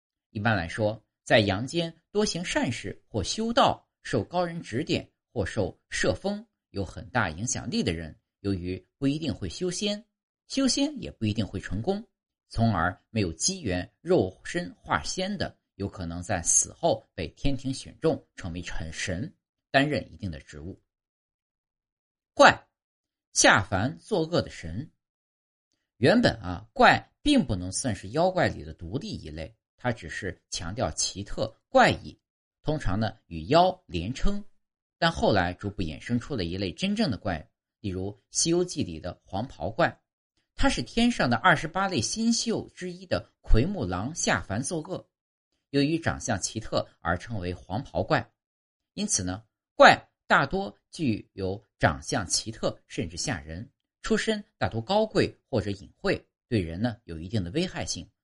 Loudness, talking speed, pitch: -27 LUFS, 220 characters per minute, 110 Hz